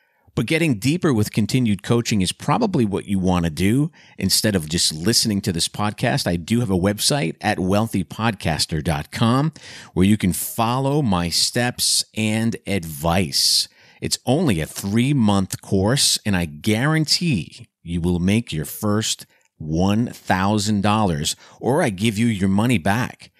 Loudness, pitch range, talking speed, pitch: -20 LUFS, 95-120 Hz, 145 wpm, 105 Hz